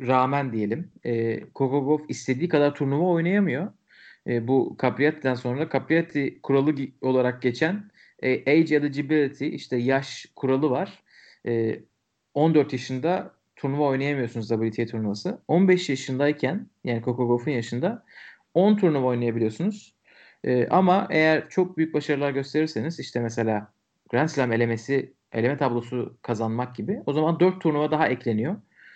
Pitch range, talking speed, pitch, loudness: 120-155 Hz, 130 wpm, 135 Hz, -25 LUFS